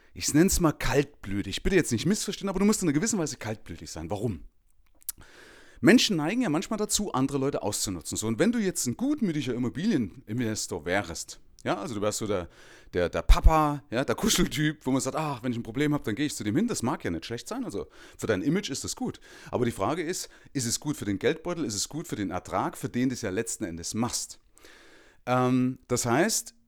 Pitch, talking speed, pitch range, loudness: 130 Hz, 235 wpm, 110-155 Hz, -28 LUFS